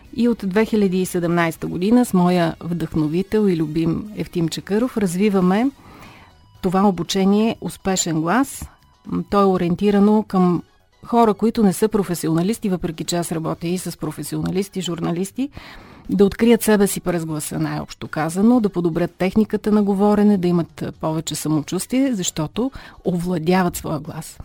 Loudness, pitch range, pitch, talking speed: -20 LUFS, 165-210 Hz, 180 Hz, 135 wpm